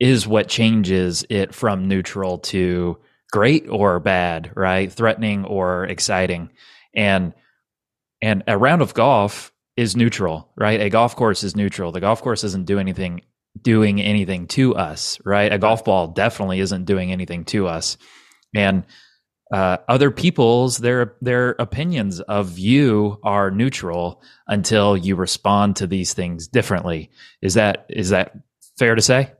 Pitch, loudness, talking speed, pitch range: 100 Hz, -19 LUFS, 150 wpm, 95-115 Hz